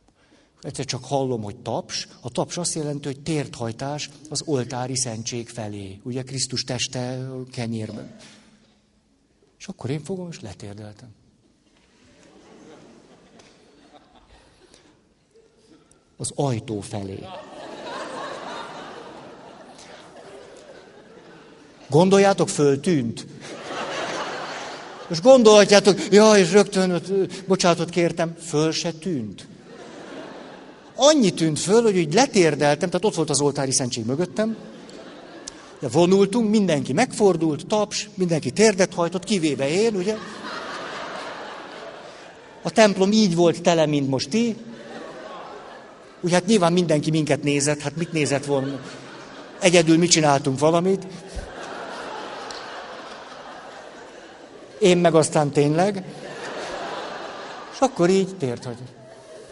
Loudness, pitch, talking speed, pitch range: -21 LUFS, 160 Hz, 95 wpm, 135-190 Hz